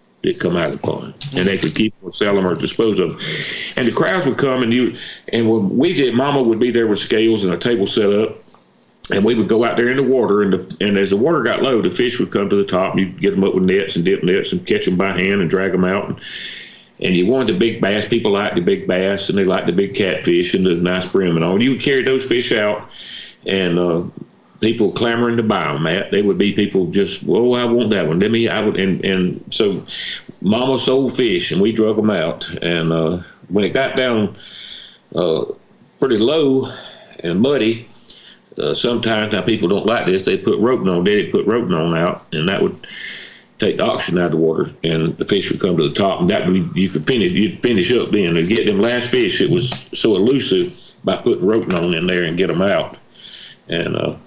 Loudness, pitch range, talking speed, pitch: -17 LUFS, 90-120 Hz, 250 wpm, 100 Hz